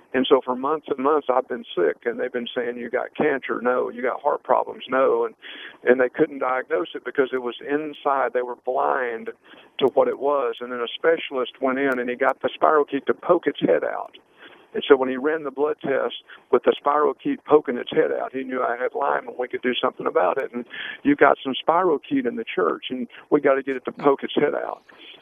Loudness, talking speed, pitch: -23 LUFS, 250 wpm, 140 Hz